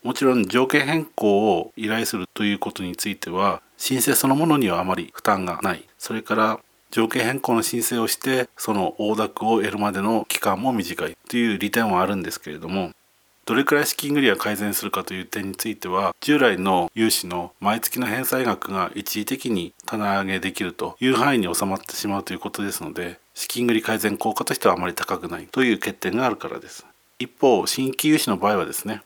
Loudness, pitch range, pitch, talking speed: -22 LUFS, 100-120 Hz, 110 Hz, 410 characters per minute